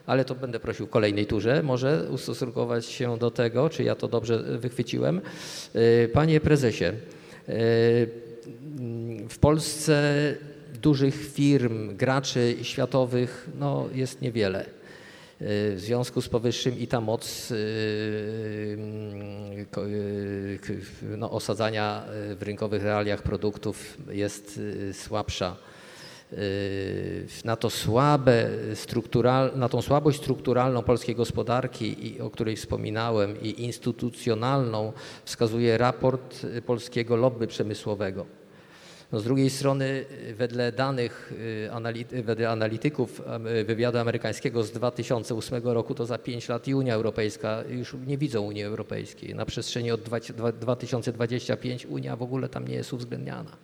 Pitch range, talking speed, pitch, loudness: 110-130 Hz, 105 wpm, 120 Hz, -27 LUFS